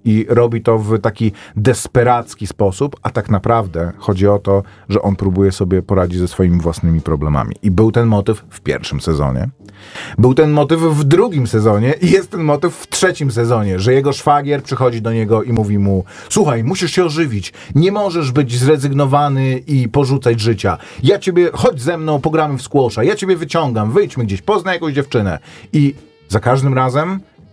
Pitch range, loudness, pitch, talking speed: 100-145 Hz, -15 LUFS, 120 Hz, 180 wpm